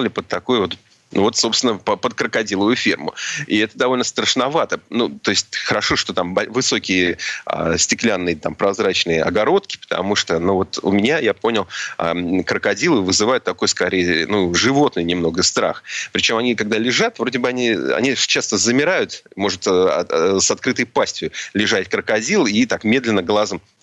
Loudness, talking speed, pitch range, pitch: -18 LUFS, 160 wpm, 85-110 Hz, 95 Hz